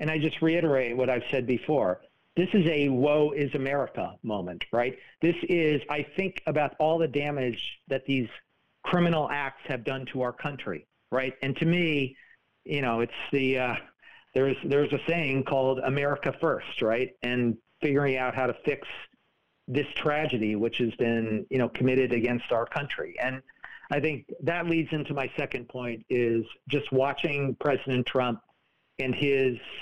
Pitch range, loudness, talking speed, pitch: 125-145 Hz, -28 LUFS, 165 wpm, 135 Hz